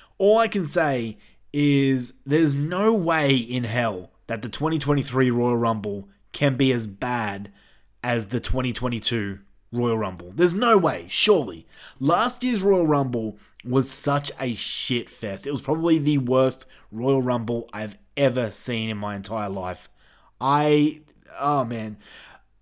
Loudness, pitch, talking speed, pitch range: -23 LUFS, 125 Hz, 145 wpm, 110-145 Hz